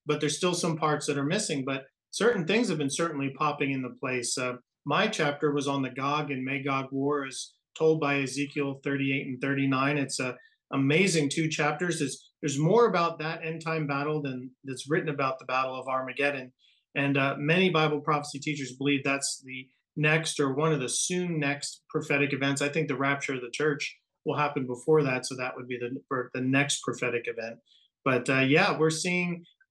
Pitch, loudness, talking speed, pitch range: 145 Hz, -28 LUFS, 200 wpm, 135-155 Hz